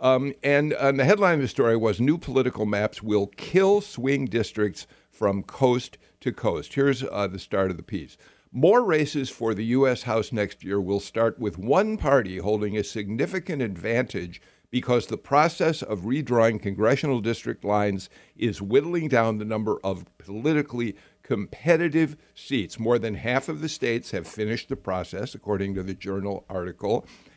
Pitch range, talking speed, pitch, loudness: 100-140 Hz, 165 wpm, 115 Hz, -25 LUFS